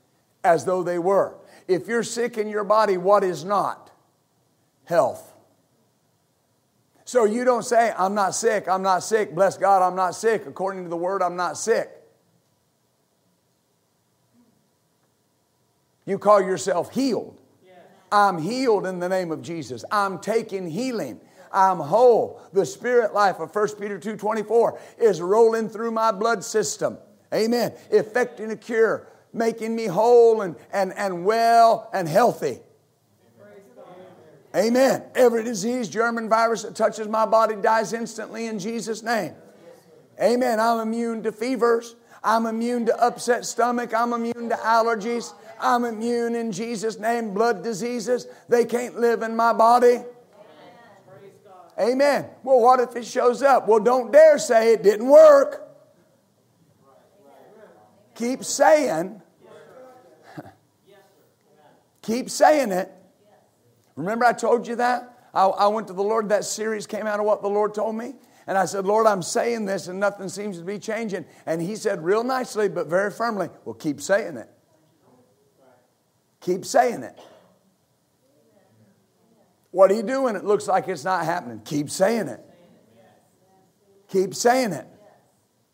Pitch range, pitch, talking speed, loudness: 195-235 Hz, 220 Hz, 145 wpm, -22 LUFS